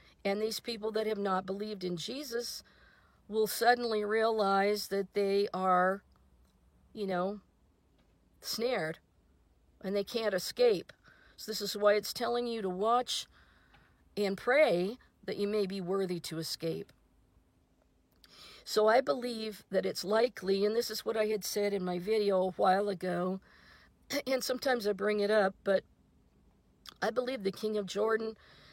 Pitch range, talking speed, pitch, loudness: 185-220 Hz, 150 wpm, 205 Hz, -32 LUFS